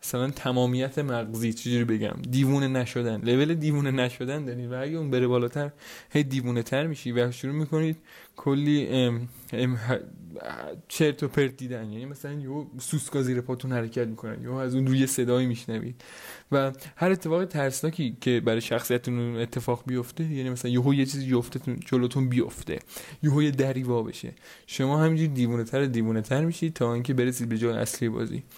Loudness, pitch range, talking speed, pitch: -27 LUFS, 120-140 Hz, 170 wpm, 130 Hz